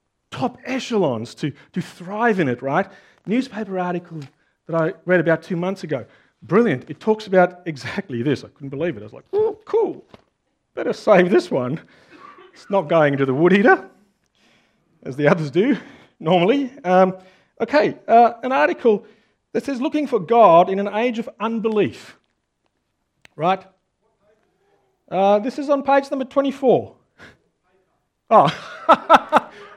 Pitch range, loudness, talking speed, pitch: 165-235 Hz, -19 LUFS, 145 wpm, 195 Hz